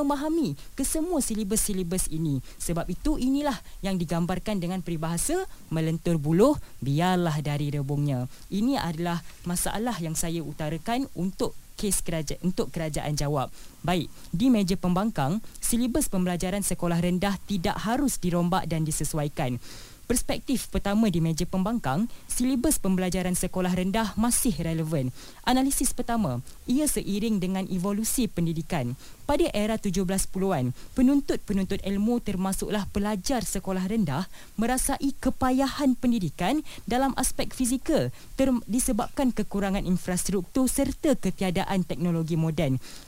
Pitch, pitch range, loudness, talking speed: 195 Hz, 170-240 Hz, -27 LUFS, 115 wpm